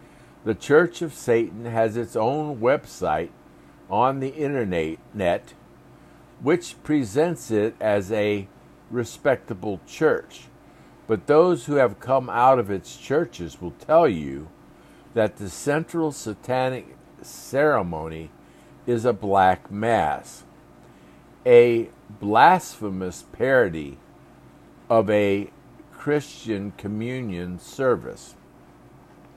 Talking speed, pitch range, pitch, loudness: 95 wpm, 95-135 Hz, 110 Hz, -23 LUFS